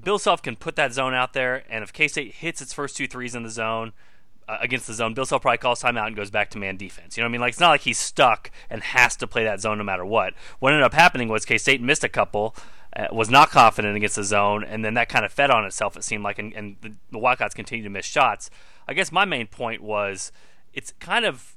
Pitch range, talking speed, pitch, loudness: 105-125 Hz, 280 wpm, 115 Hz, -21 LUFS